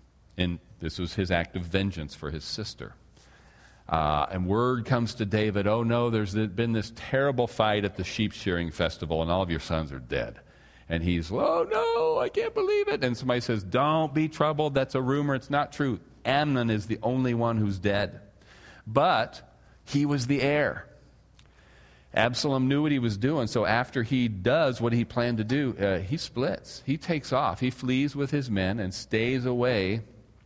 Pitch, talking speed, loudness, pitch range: 120 Hz, 190 wpm, -27 LUFS, 100-135 Hz